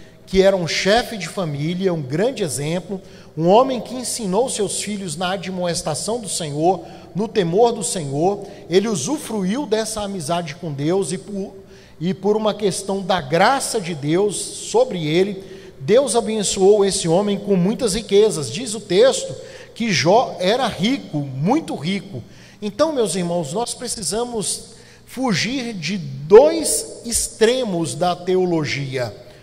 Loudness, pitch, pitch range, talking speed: -19 LUFS, 195 Hz, 175-225 Hz, 140 wpm